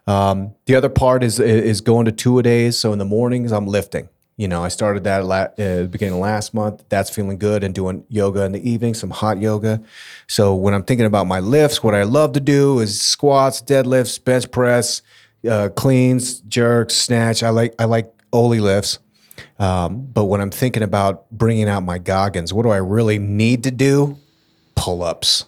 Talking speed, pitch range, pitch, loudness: 200 wpm, 100-120 Hz, 110 Hz, -17 LUFS